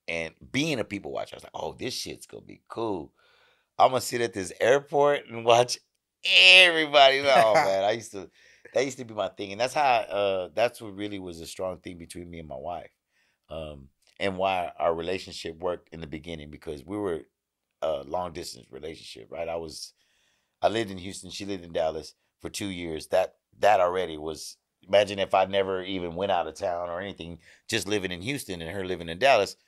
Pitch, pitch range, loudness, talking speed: 95 Hz, 85-110 Hz, -25 LUFS, 210 wpm